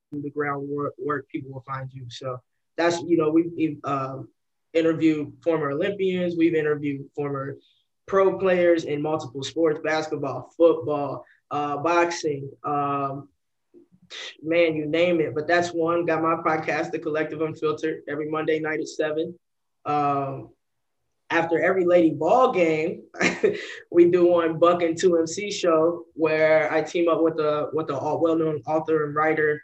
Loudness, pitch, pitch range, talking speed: -23 LUFS, 155 Hz, 145-170 Hz, 150 wpm